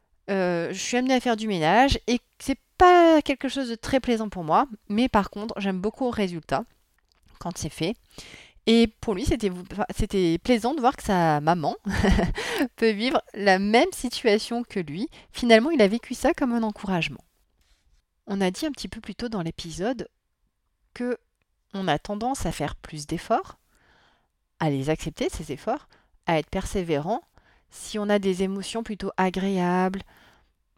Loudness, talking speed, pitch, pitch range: -25 LUFS, 170 wpm, 205 Hz, 175-240 Hz